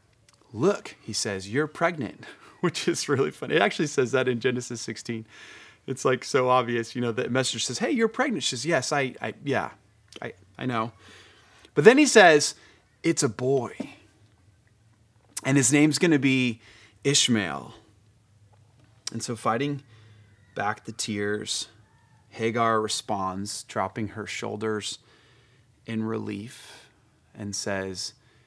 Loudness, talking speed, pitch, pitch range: -25 LUFS, 140 wpm, 115 Hz, 110-130 Hz